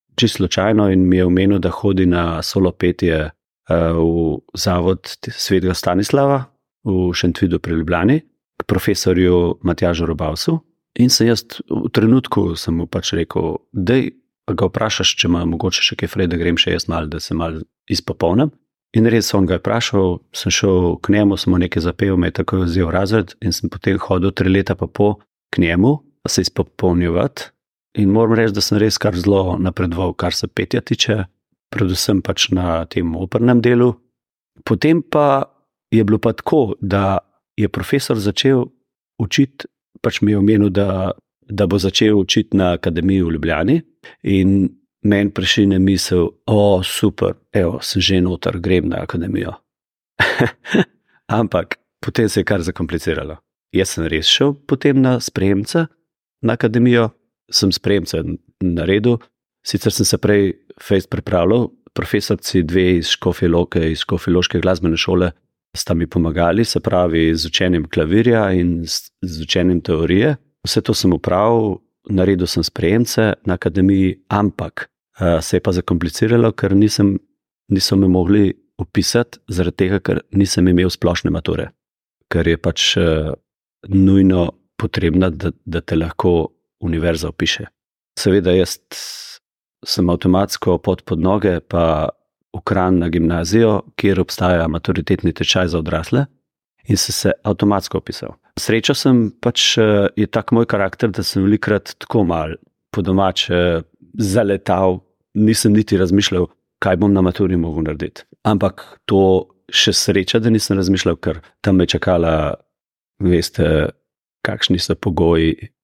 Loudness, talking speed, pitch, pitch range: -17 LUFS, 145 wpm, 95 Hz, 90-110 Hz